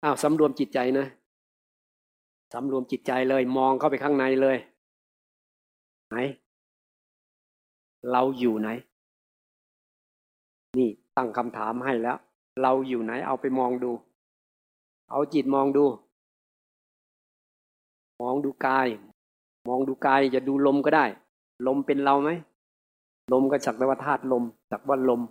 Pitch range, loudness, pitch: 120-135 Hz, -26 LUFS, 130 Hz